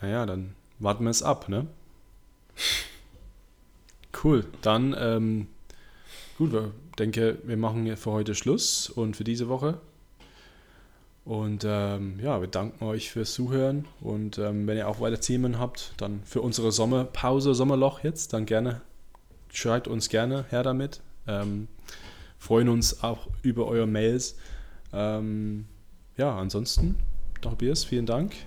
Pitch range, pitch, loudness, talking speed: 100-125 Hz, 110 Hz, -28 LUFS, 135 wpm